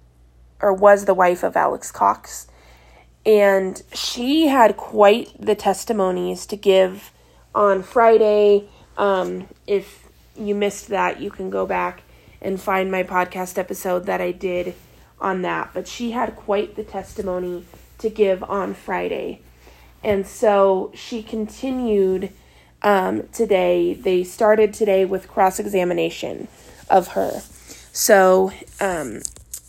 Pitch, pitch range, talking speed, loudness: 190 Hz, 180-210 Hz, 125 wpm, -19 LUFS